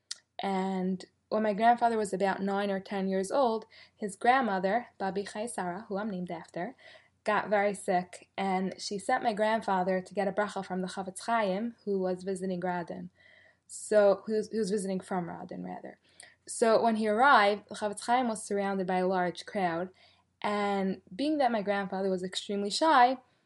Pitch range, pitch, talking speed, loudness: 185-215 Hz, 200 Hz, 175 wpm, -30 LUFS